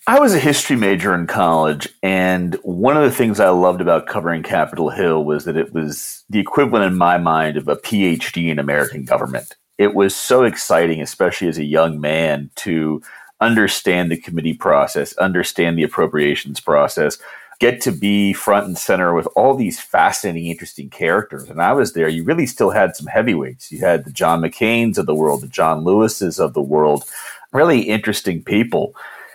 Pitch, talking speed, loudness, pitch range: 85 Hz, 185 wpm, -17 LUFS, 80-95 Hz